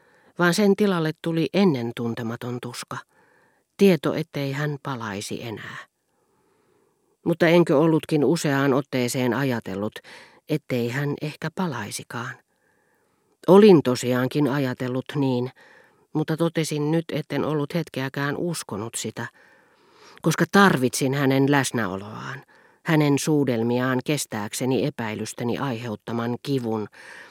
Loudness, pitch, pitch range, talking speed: -23 LUFS, 140 Hz, 125-165 Hz, 95 wpm